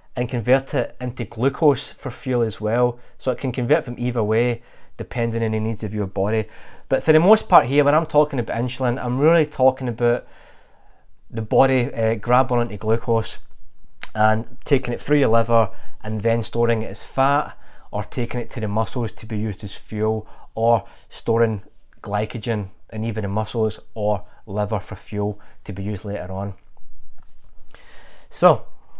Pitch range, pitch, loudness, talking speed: 110-125 Hz, 115 Hz, -21 LUFS, 175 wpm